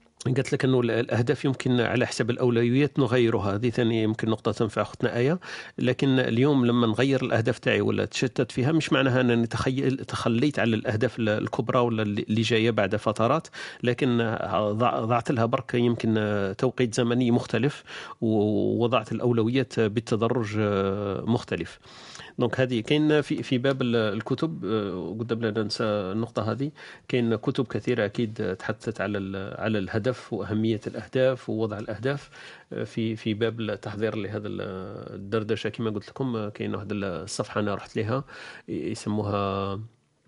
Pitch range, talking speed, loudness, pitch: 110-125 Hz, 135 wpm, -26 LUFS, 115 Hz